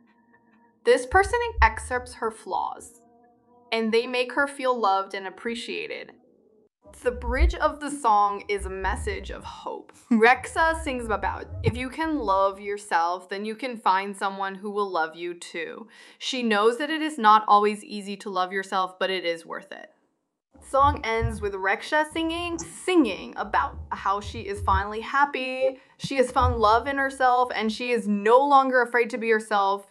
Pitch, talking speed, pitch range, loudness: 235 Hz, 170 wpm, 205-275 Hz, -24 LUFS